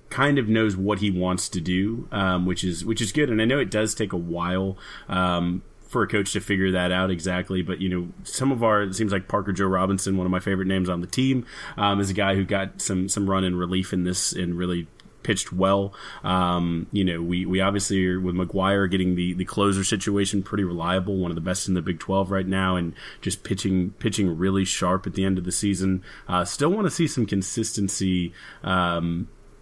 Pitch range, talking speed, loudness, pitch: 90-100 Hz, 230 wpm, -24 LUFS, 95 Hz